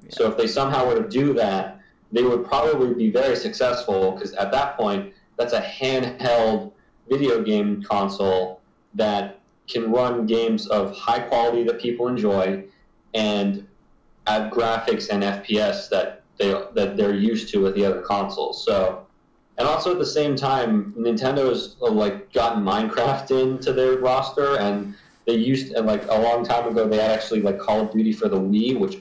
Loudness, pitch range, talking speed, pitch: -22 LUFS, 105-130 Hz, 170 wpm, 115 Hz